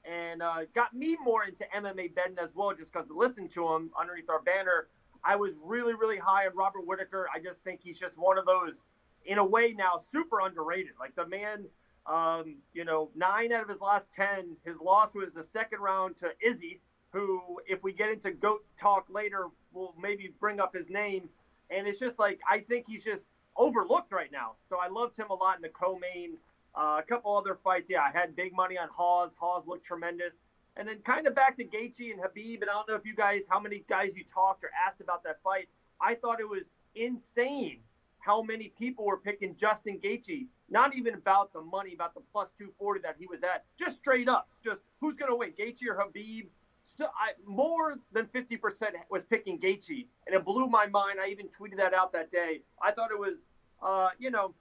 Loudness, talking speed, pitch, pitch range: -32 LUFS, 220 wpm, 195 Hz, 180-225 Hz